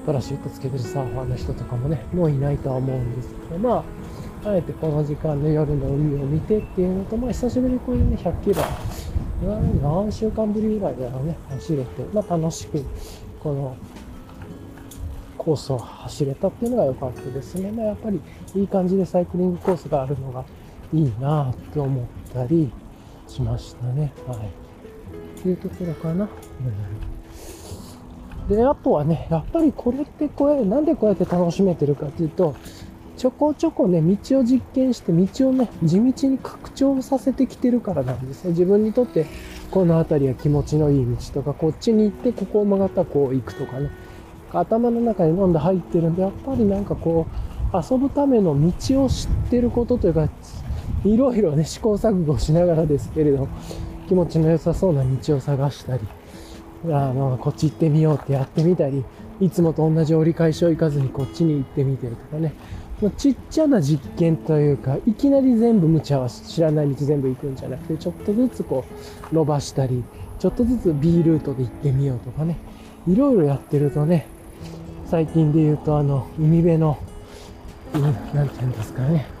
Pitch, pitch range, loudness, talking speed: 155 Hz, 135-190 Hz, -21 LUFS, 375 characters per minute